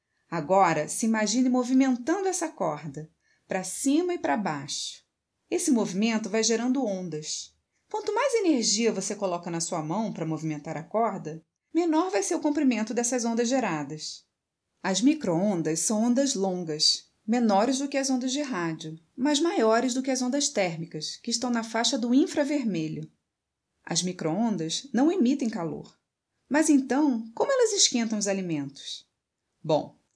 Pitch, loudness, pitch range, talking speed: 225 Hz, -26 LUFS, 175-275 Hz, 145 wpm